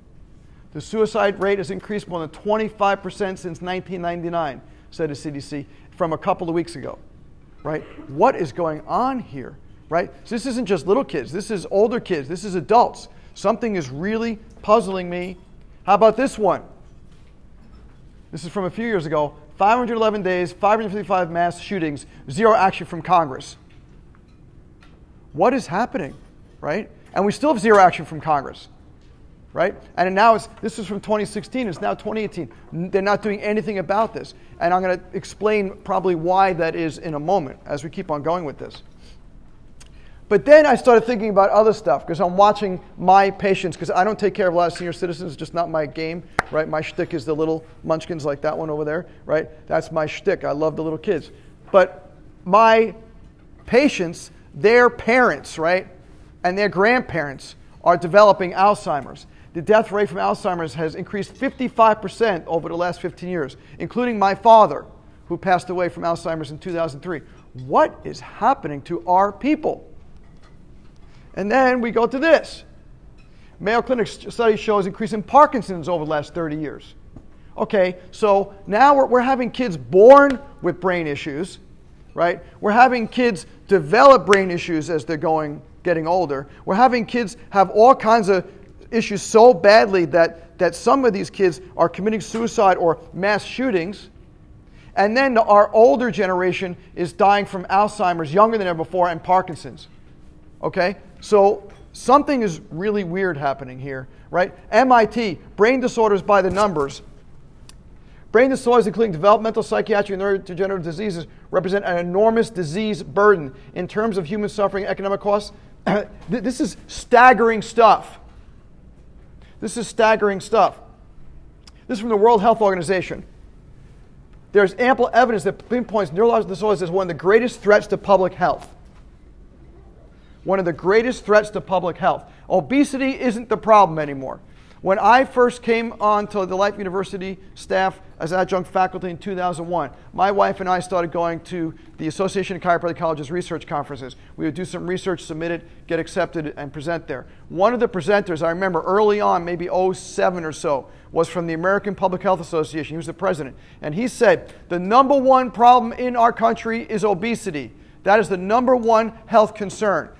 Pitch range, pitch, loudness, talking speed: 170-215 Hz, 190 Hz, -19 LUFS, 165 wpm